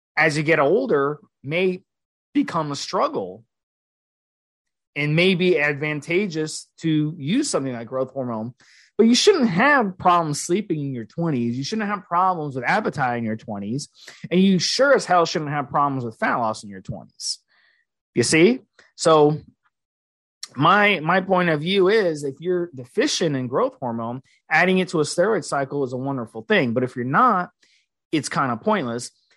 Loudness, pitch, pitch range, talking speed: -21 LUFS, 155 Hz, 130-180 Hz, 170 wpm